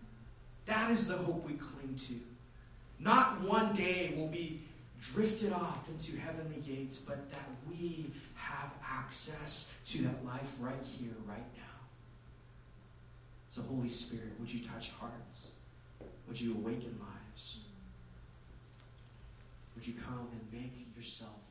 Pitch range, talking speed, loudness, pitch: 120-150 Hz, 130 wpm, -39 LUFS, 120 Hz